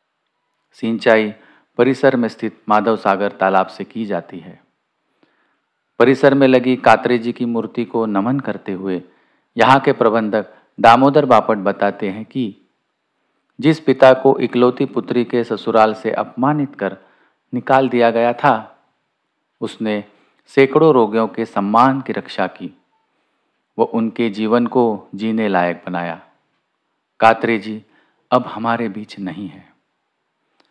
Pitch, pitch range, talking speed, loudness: 115 Hz, 105-125 Hz, 130 wpm, -16 LUFS